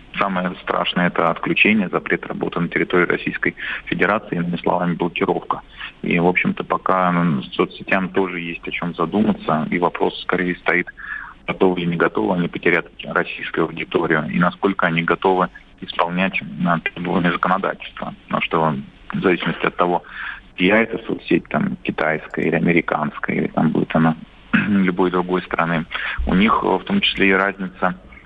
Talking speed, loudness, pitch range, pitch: 145 wpm, -19 LUFS, 85-95 Hz, 90 Hz